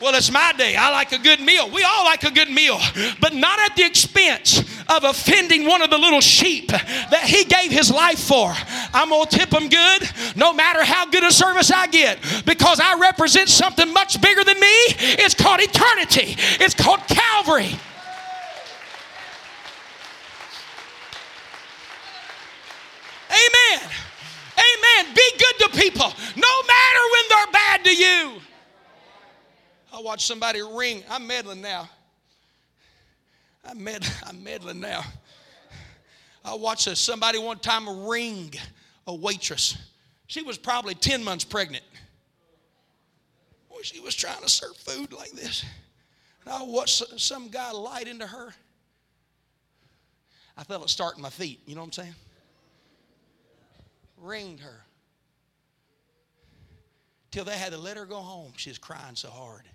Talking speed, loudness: 145 wpm, -15 LUFS